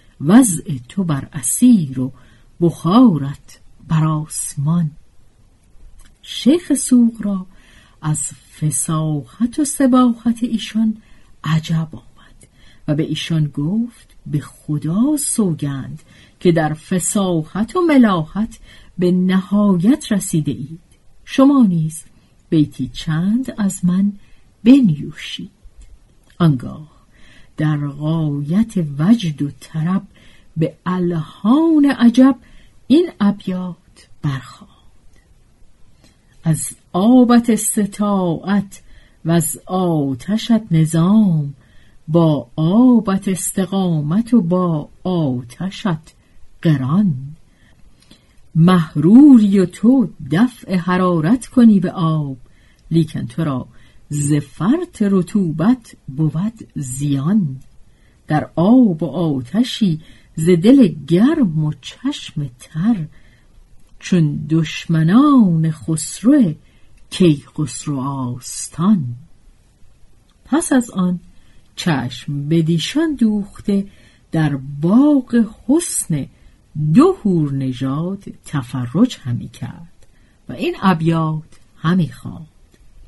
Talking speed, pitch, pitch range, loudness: 85 wpm, 165 Hz, 145-210 Hz, -16 LUFS